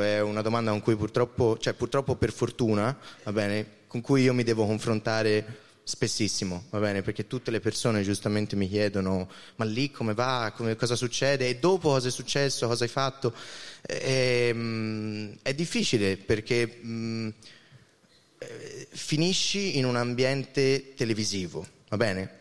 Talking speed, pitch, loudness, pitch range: 145 wpm, 115 Hz, -28 LUFS, 105-130 Hz